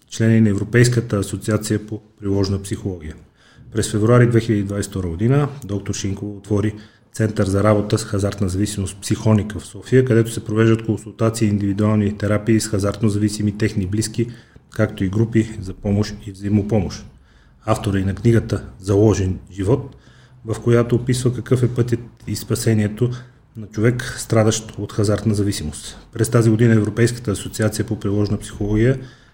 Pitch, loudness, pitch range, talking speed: 110 Hz, -19 LUFS, 100-115 Hz, 145 wpm